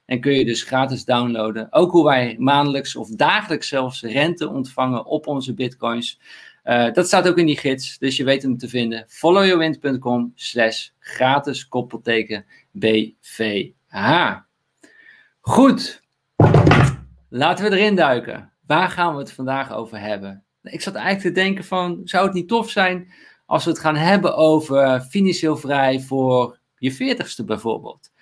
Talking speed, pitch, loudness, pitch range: 150 wpm, 135 Hz, -19 LUFS, 125-175 Hz